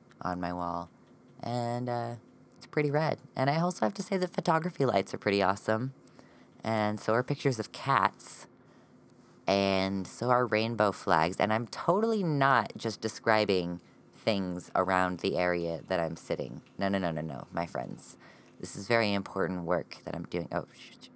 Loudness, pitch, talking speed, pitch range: -31 LUFS, 110 Hz, 175 wpm, 90-125 Hz